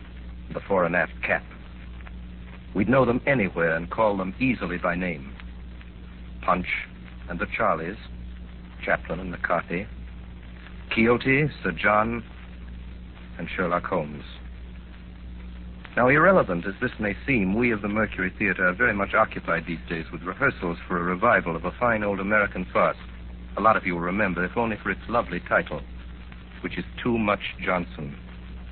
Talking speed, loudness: 155 wpm, -24 LUFS